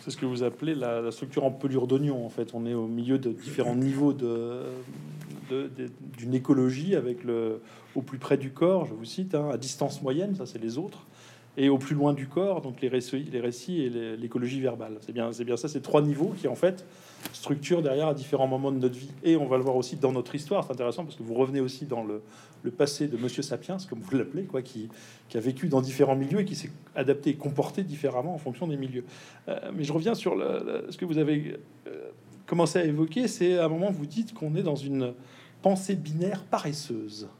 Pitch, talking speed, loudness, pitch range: 135 Hz, 240 wpm, -29 LUFS, 125-160 Hz